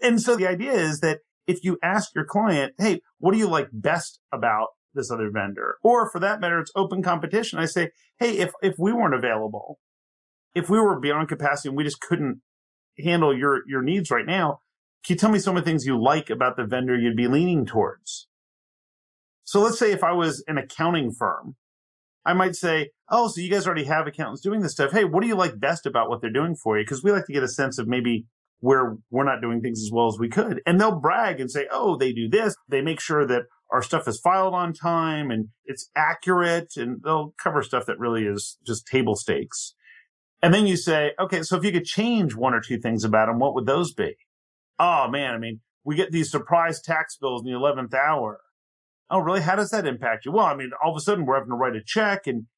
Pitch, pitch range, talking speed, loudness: 155 Hz, 125-185 Hz, 235 wpm, -23 LUFS